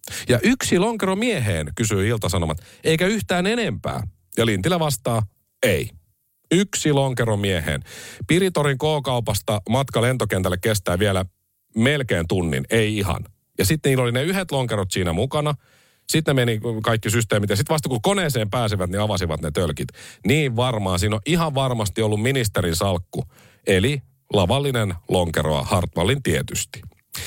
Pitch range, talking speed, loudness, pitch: 95-140 Hz, 140 wpm, -21 LUFS, 115 Hz